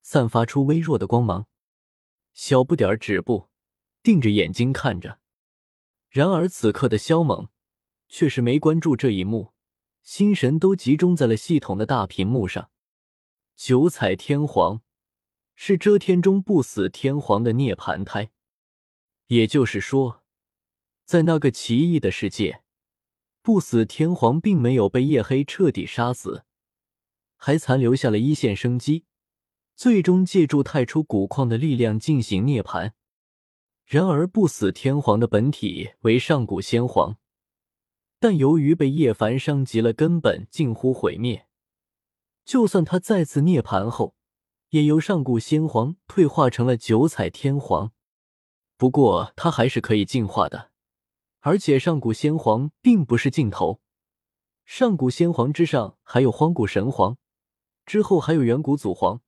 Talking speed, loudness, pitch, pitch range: 210 characters per minute, -21 LUFS, 135 Hz, 115-160 Hz